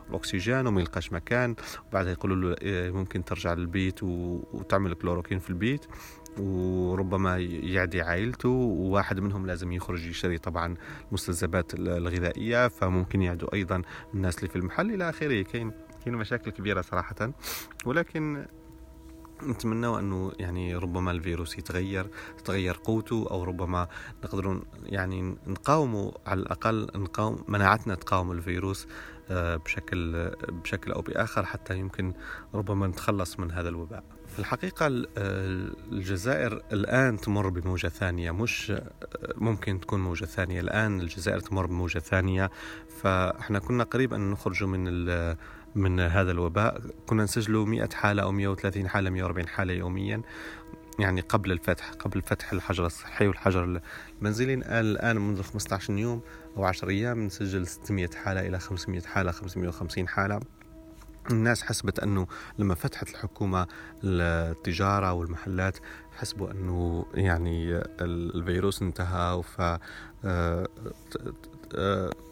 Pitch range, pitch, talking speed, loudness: 90-105 Hz, 95 Hz, 120 wpm, -30 LUFS